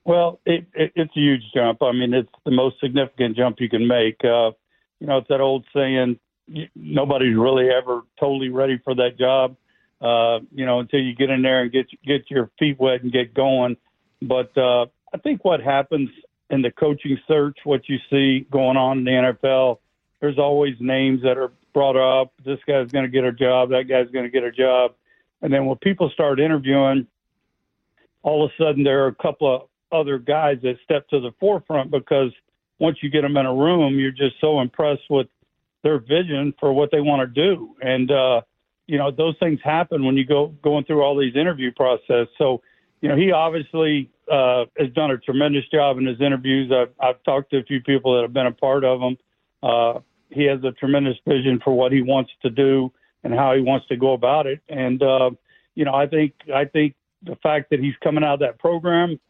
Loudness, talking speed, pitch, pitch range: -20 LUFS, 215 wpm, 135 Hz, 130-145 Hz